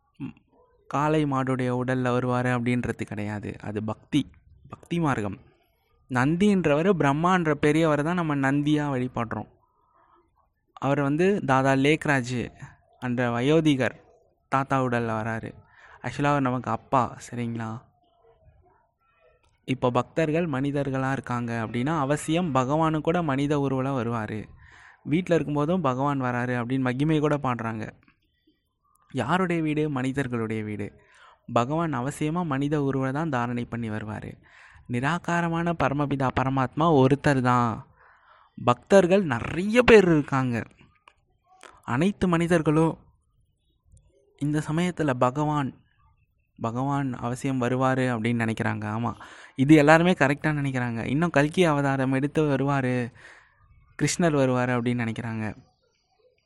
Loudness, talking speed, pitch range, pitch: -25 LUFS, 100 wpm, 120-150 Hz, 135 Hz